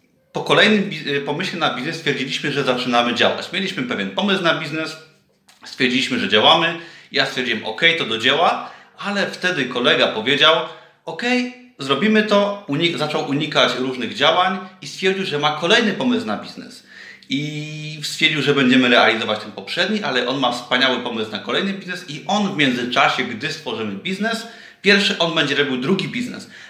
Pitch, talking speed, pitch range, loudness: 155 Hz, 160 wpm, 130-190 Hz, -18 LUFS